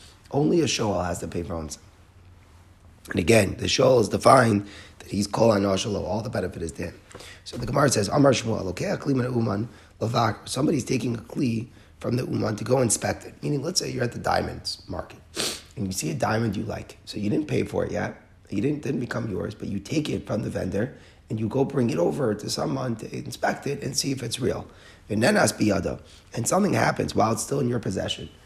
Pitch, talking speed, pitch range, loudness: 105 Hz, 215 wpm, 95-120 Hz, -25 LUFS